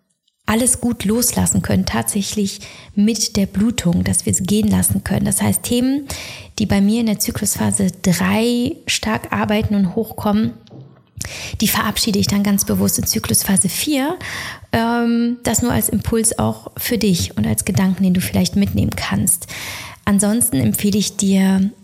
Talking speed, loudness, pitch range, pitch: 155 wpm, -17 LUFS, 135-225 Hz, 200 Hz